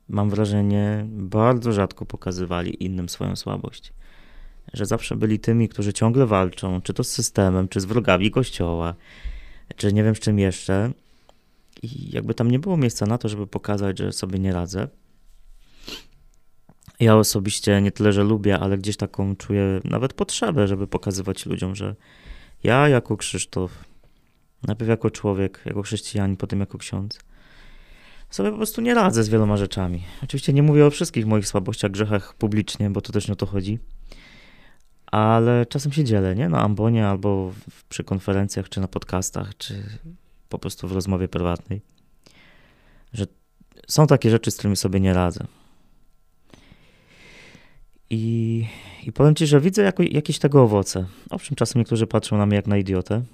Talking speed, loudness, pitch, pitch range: 160 wpm, -22 LUFS, 105 Hz, 95-115 Hz